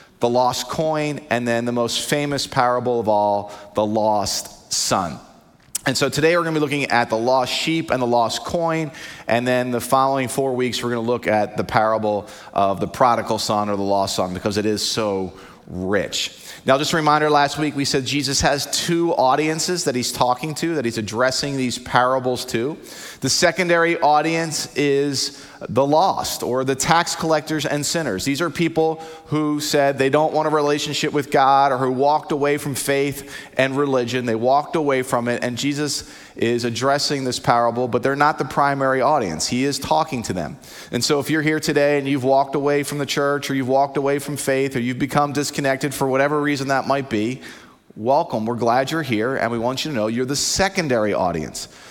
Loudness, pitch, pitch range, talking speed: -20 LUFS, 135 Hz, 120-150 Hz, 205 wpm